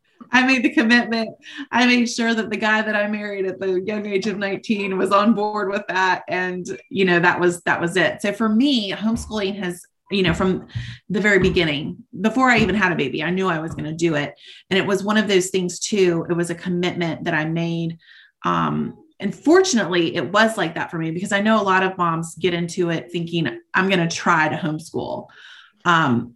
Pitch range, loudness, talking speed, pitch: 170-215 Hz, -20 LUFS, 225 wpm, 190 Hz